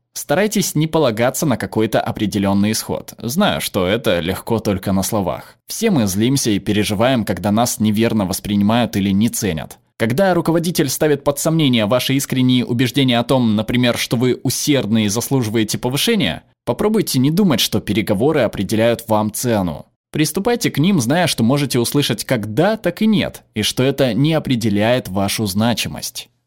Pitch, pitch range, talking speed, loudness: 120 Hz, 105-145 Hz, 160 wpm, -17 LUFS